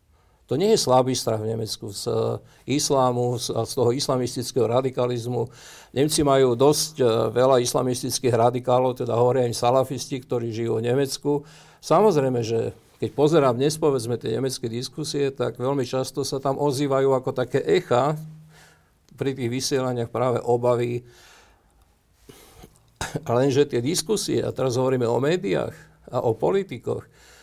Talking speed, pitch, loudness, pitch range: 135 wpm, 130 Hz, -23 LUFS, 120-140 Hz